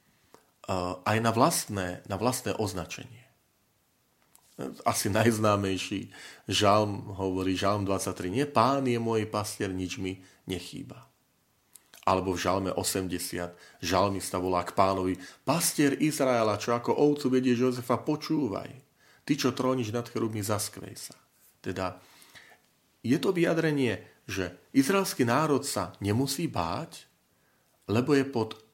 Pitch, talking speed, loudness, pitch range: 105 Hz, 115 wpm, -28 LUFS, 95-130 Hz